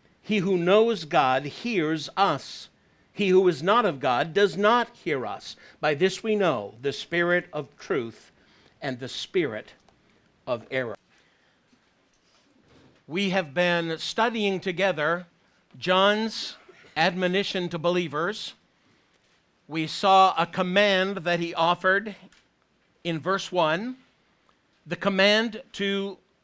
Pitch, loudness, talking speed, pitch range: 185 Hz, -25 LUFS, 115 wpm, 170-200 Hz